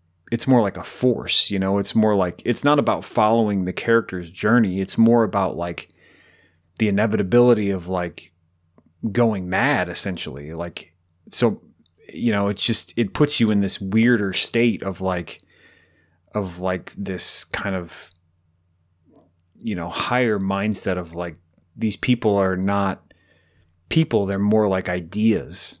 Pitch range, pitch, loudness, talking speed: 90-110 Hz, 95 Hz, -21 LUFS, 145 wpm